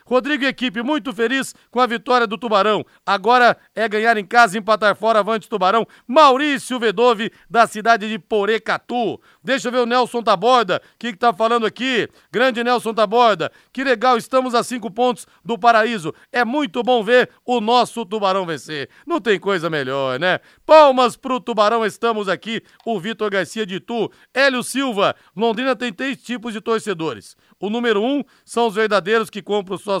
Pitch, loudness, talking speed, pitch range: 230 Hz, -18 LUFS, 175 wpm, 210-245 Hz